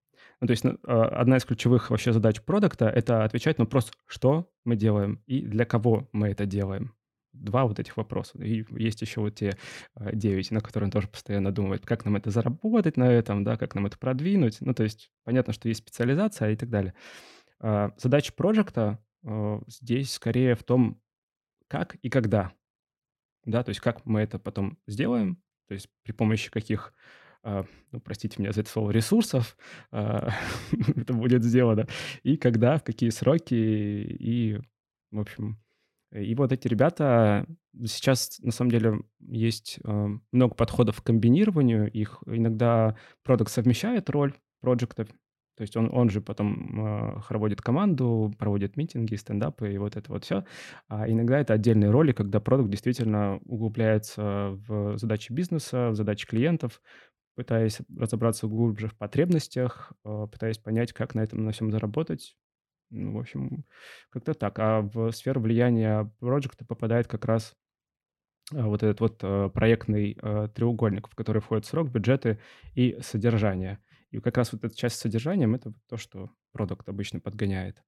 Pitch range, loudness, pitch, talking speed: 105-125 Hz, -27 LUFS, 115 Hz, 160 wpm